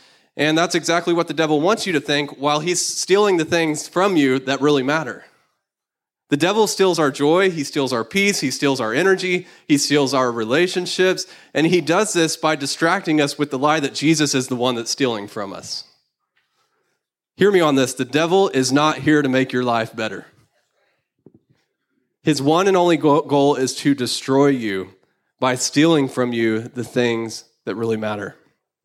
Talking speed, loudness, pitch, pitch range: 185 wpm, -18 LUFS, 145 Hz, 130-170 Hz